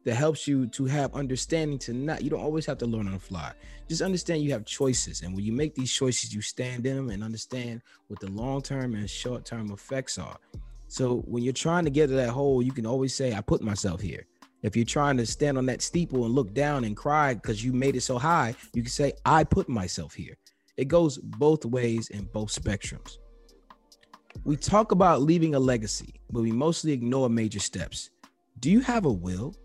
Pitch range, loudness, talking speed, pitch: 115-145 Hz, -27 LUFS, 225 wpm, 125 Hz